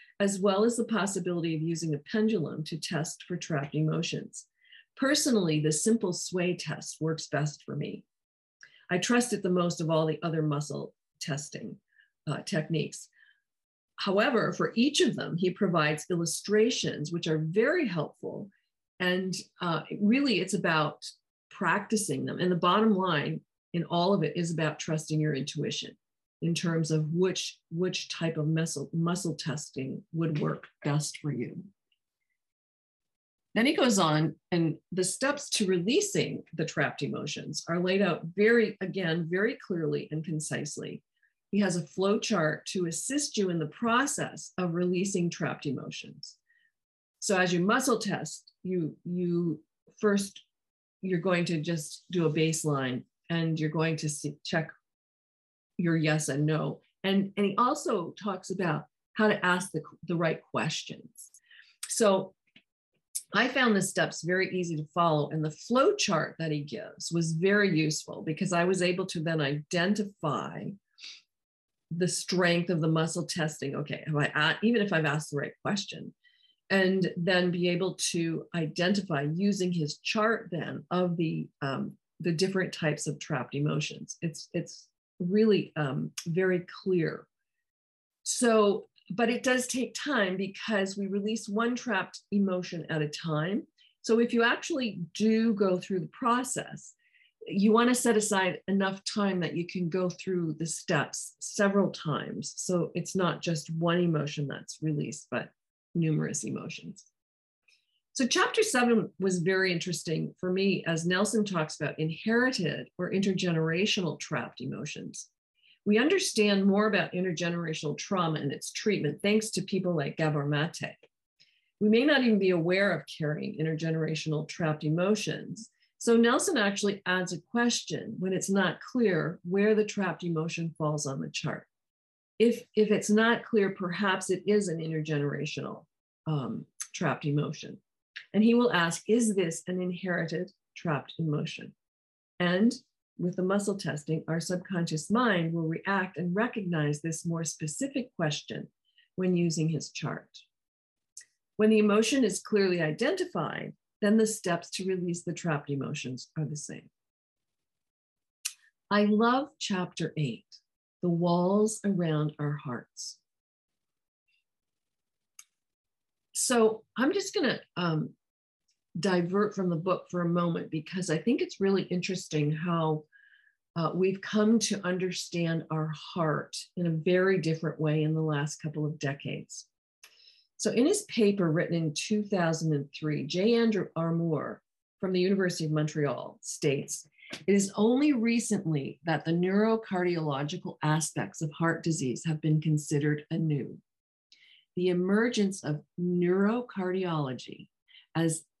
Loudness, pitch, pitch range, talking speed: -29 LUFS, 180 Hz, 160-205 Hz, 145 wpm